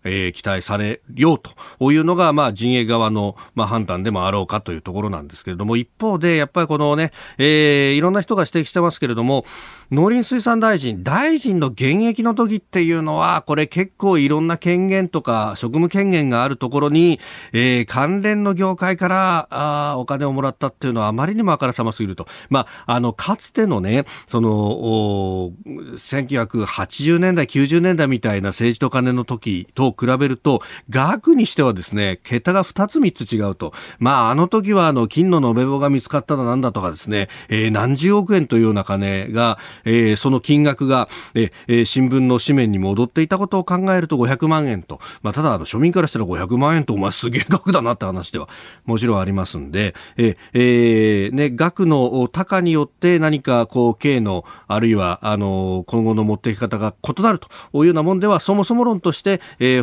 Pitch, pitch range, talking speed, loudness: 130 Hz, 110-170 Hz, 365 characters per minute, -18 LUFS